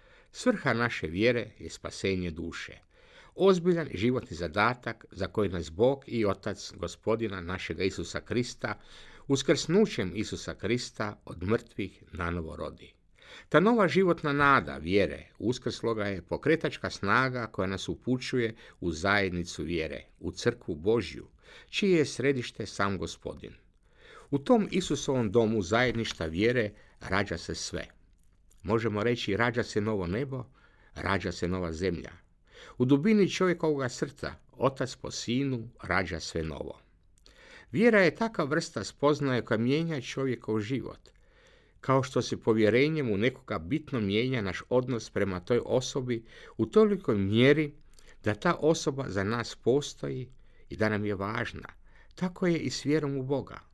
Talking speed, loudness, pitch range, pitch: 135 wpm, -29 LUFS, 95-140 Hz, 115 Hz